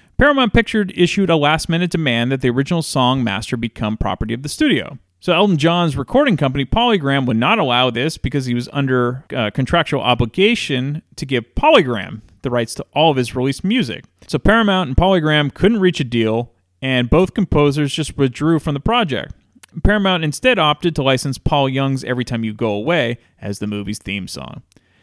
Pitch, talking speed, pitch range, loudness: 140 Hz, 185 wpm, 120-170 Hz, -17 LUFS